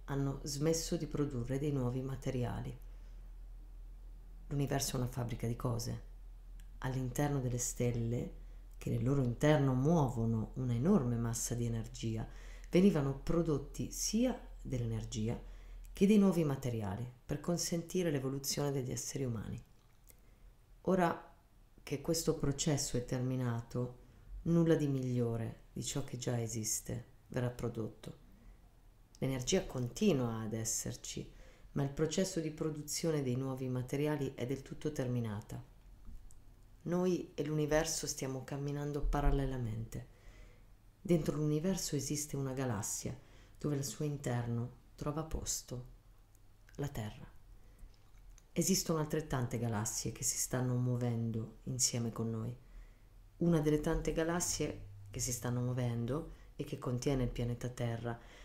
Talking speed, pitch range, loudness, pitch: 120 wpm, 115-150 Hz, -36 LUFS, 125 Hz